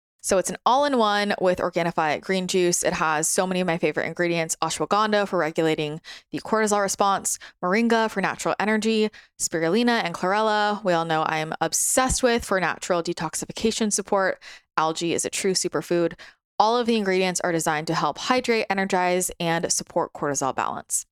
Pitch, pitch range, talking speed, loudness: 185 Hz, 165-210 Hz, 170 wpm, -23 LUFS